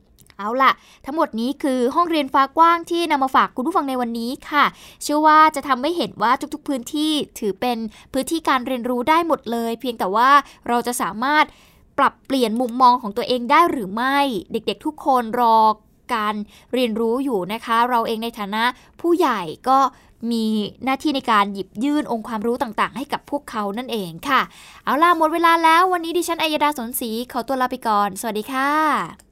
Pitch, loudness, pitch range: 255 Hz, -20 LUFS, 230-295 Hz